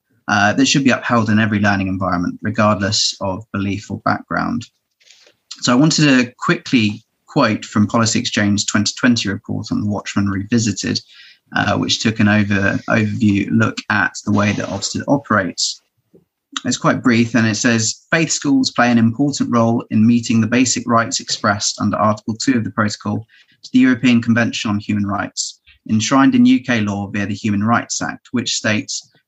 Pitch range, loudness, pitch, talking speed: 105-120 Hz, -16 LUFS, 110 Hz, 170 wpm